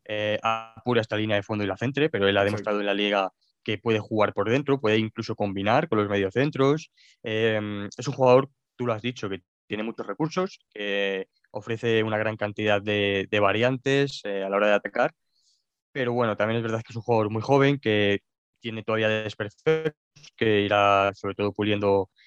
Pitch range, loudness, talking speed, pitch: 105-120 Hz, -25 LUFS, 195 wpm, 110 Hz